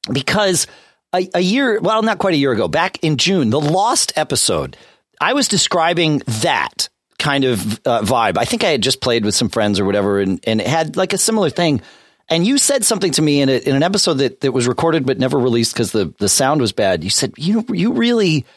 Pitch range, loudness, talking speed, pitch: 125-195 Hz, -16 LUFS, 235 wpm, 150 Hz